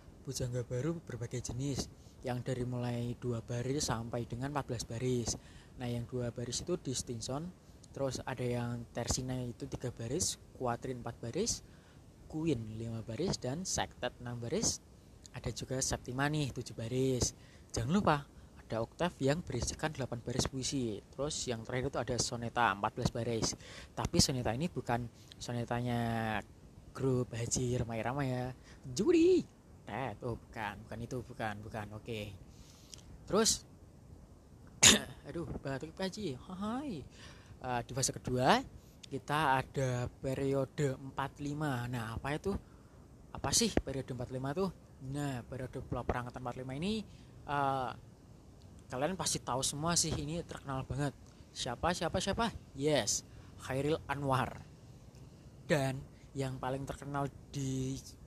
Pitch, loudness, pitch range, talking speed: 125 Hz, -36 LUFS, 120-140 Hz, 125 wpm